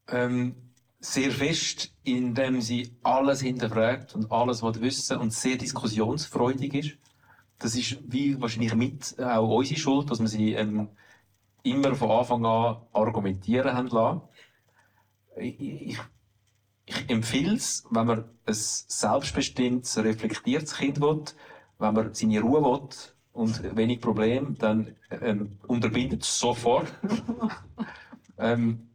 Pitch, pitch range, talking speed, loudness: 120 Hz, 110-135 Hz, 125 wpm, -27 LUFS